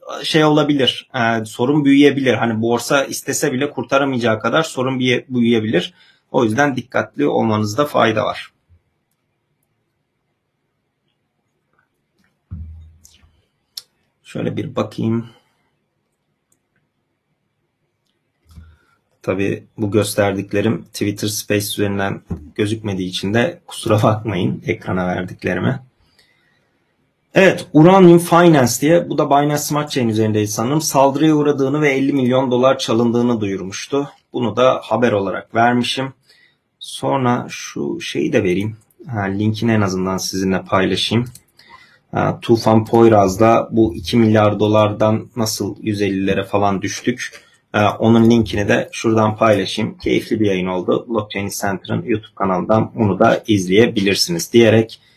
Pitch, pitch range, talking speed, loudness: 110 Hz, 100-130 Hz, 105 wpm, -16 LUFS